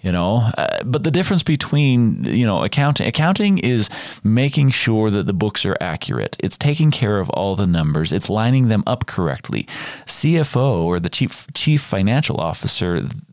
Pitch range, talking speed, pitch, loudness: 100-150 Hz, 170 wpm, 125 Hz, -18 LUFS